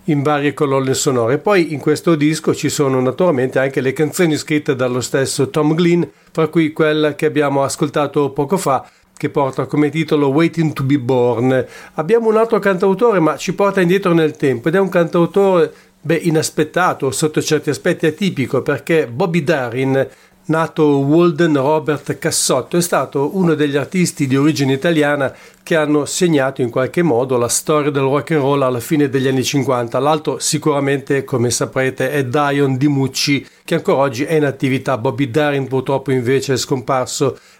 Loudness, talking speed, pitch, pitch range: -16 LUFS, 170 wpm, 150 Hz, 135-160 Hz